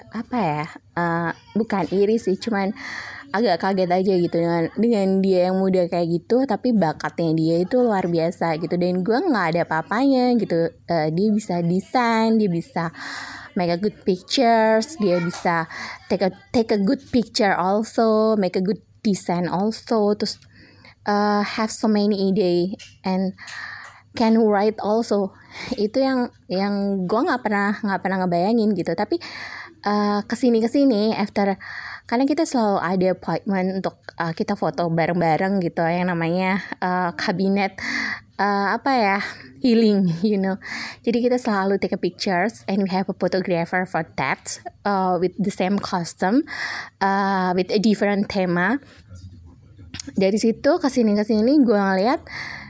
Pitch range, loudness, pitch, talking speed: 180-220 Hz, -21 LUFS, 195 Hz, 150 wpm